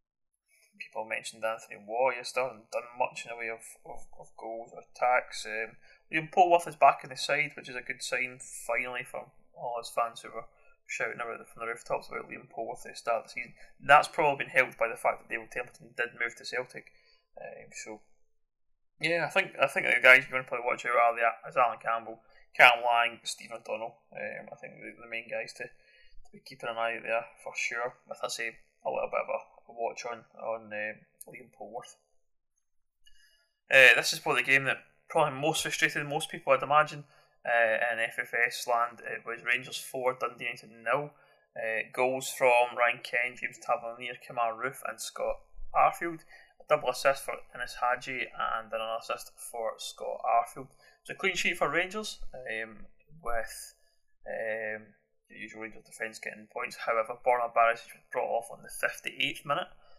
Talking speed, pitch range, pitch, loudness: 195 wpm, 115-145 Hz, 120 Hz, -29 LUFS